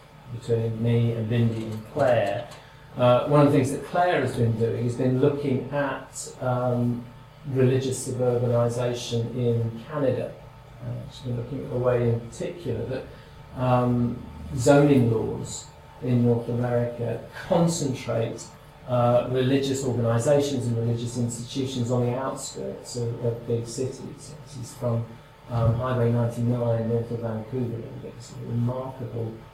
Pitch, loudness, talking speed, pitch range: 125 Hz, -25 LUFS, 140 wpm, 115-130 Hz